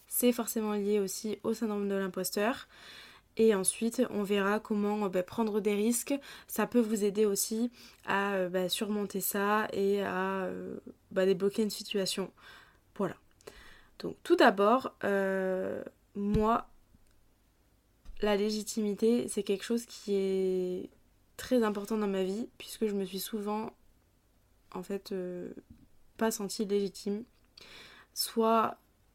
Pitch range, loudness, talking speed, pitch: 195-220 Hz, -31 LUFS, 135 wpm, 205 Hz